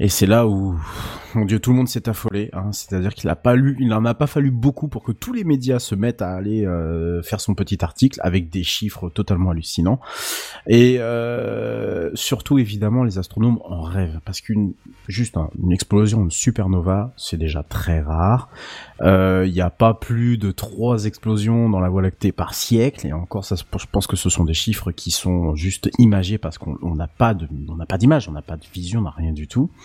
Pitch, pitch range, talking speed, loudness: 100 Hz, 90-115 Hz, 220 wpm, -20 LUFS